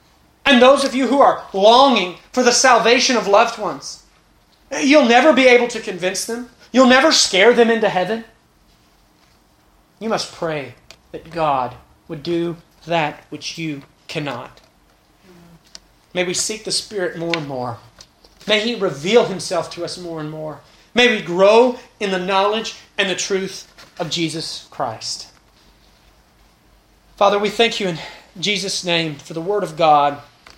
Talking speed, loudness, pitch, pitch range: 150 wpm, -16 LUFS, 190 Hz, 165-230 Hz